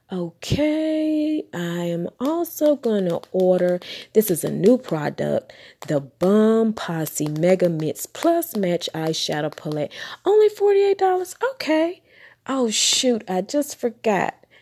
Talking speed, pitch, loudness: 115 wpm, 215 Hz, -21 LUFS